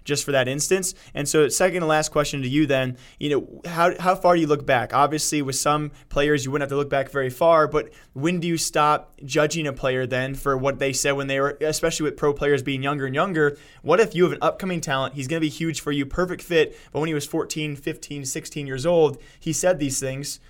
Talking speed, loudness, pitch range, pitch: 255 wpm, -22 LUFS, 140-160 Hz, 150 Hz